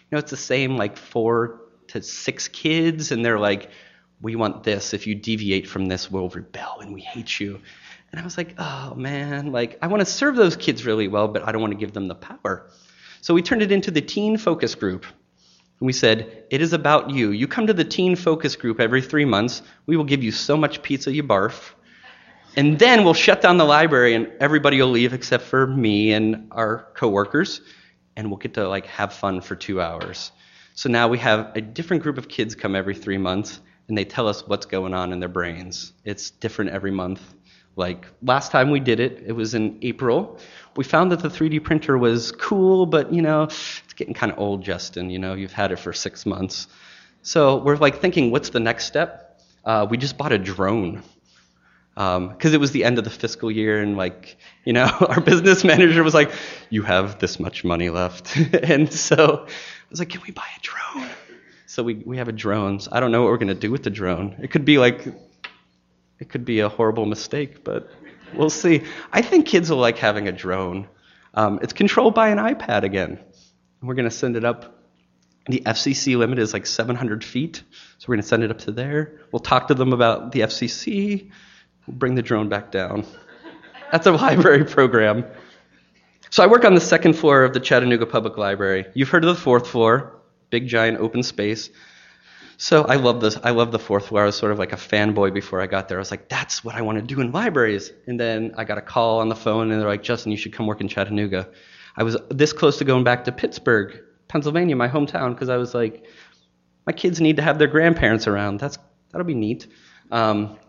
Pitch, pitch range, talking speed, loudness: 115 Hz, 100-145 Hz, 220 wpm, -20 LUFS